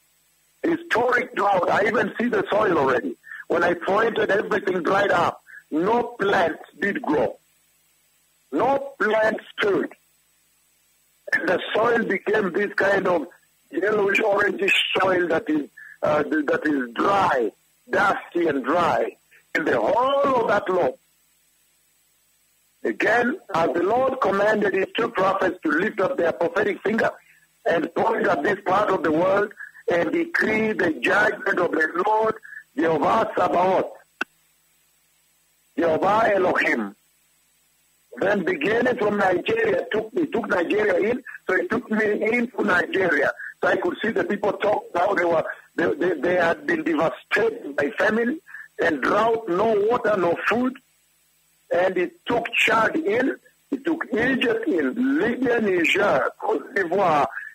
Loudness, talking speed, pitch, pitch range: -22 LUFS, 135 wpm, 220 Hz, 180-290 Hz